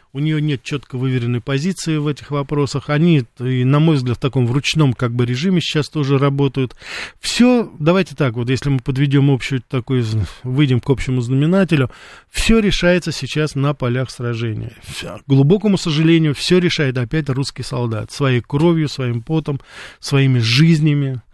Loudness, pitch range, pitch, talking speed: -17 LUFS, 125-155 Hz, 140 Hz, 155 wpm